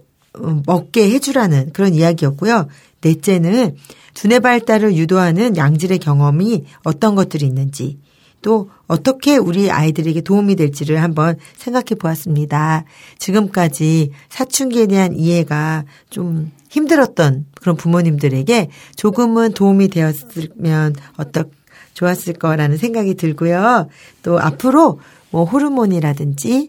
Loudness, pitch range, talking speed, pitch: -15 LUFS, 155-210 Hz, 290 characters per minute, 170 Hz